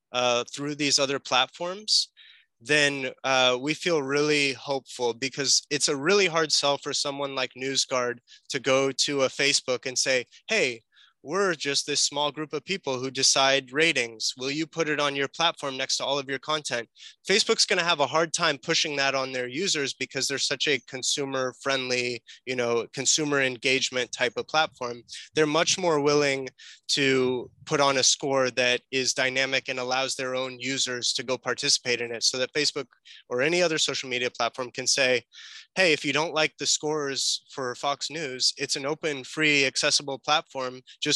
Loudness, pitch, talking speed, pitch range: -25 LUFS, 135 Hz, 185 wpm, 130-150 Hz